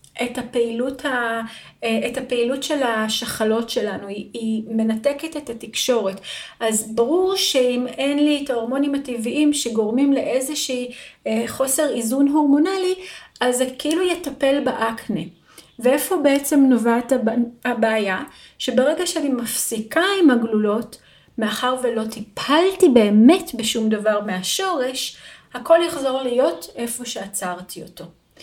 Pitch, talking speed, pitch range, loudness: 250 Hz, 110 wpm, 225-285 Hz, -20 LUFS